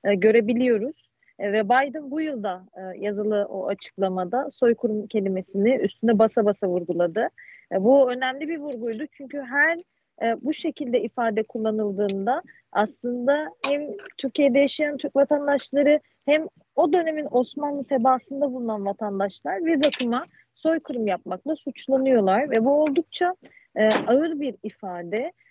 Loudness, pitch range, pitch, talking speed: -24 LUFS, 215-290 Hz, 255 Hz, 125 wpm